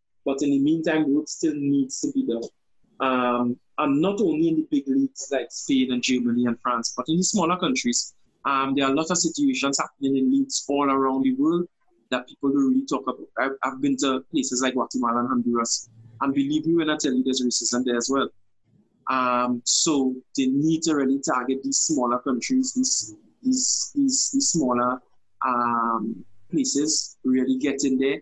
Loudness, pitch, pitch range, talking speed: -23 LUFS, 135 Hz, 125-160 Hz, 195 wpm